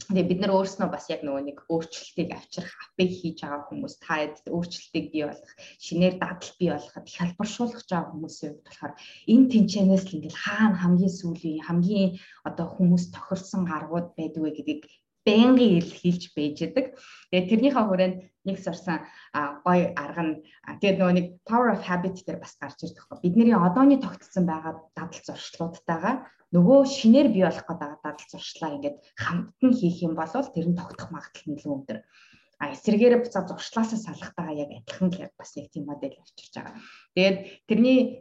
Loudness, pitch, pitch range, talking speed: -25 LUFS, 175 Hz, 155-195 Hz, 170 wpm